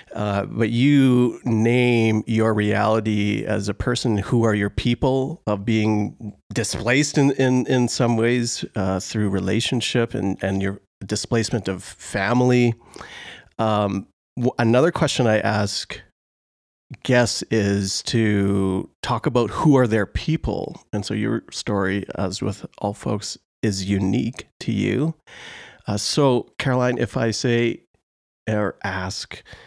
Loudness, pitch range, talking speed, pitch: -21 LUFS, 100-125 Hz, 130 wpm, 110 Hz